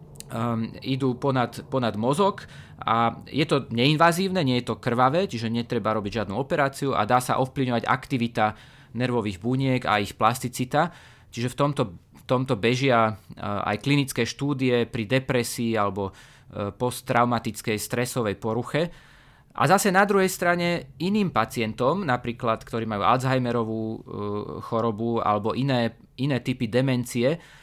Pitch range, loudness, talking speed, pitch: 115-135 Hz, -25 LUFS, 130 wpm, 125 Hz